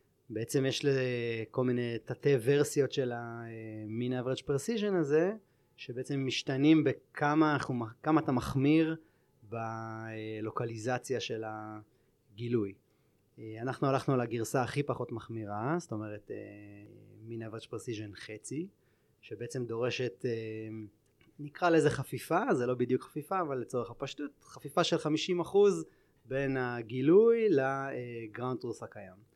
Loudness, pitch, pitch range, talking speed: -32 LUFS, 125 Hz, 115-145 Hz, 105 wpm